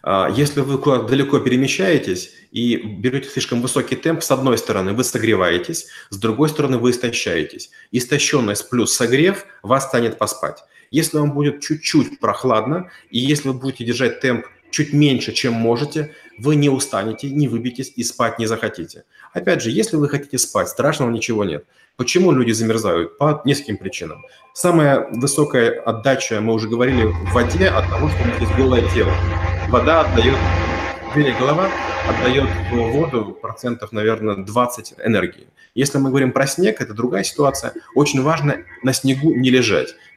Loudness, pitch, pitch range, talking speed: -18 LUFS, 125 Hz, 110-145 Hz, 155 wpm